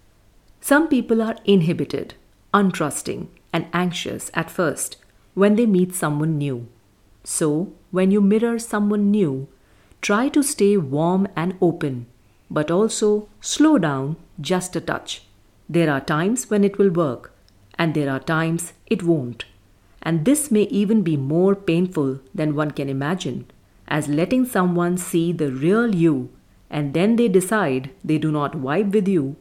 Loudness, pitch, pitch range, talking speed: -21 LUFS, 170 Hz, 140-200 Hz, 150 wpm